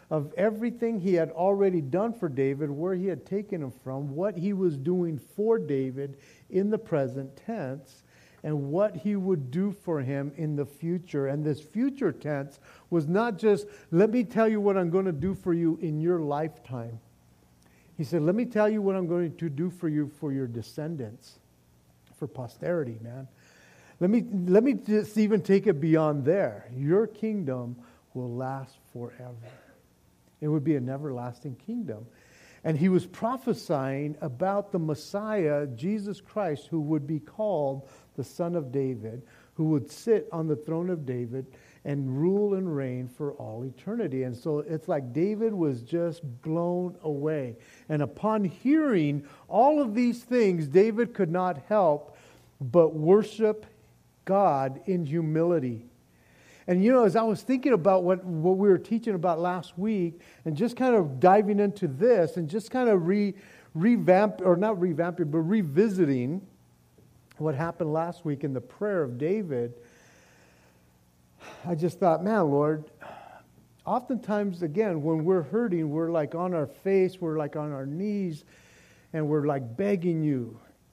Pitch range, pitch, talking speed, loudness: 140-195 Hz, 165 Hz, 165 wpm, -27 LUFS